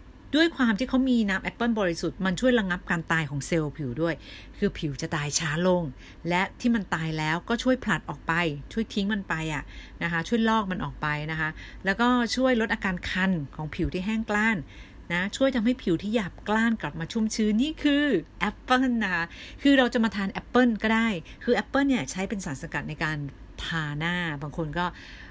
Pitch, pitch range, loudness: 190 Hz, 160-230 Hz, -26 LUFS